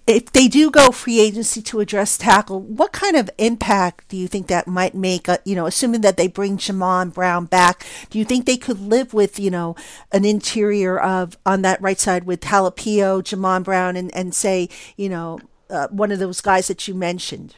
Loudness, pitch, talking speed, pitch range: -18 LUFS, 195 Hz, 210 wpm, 185-215 Hz